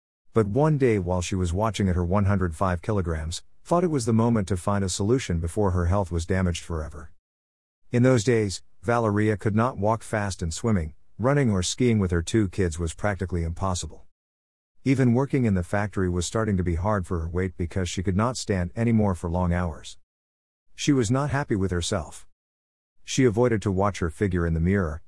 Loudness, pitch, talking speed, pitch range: -25 LUFS, 95 Hz, 200 wpm, 85-110 Hz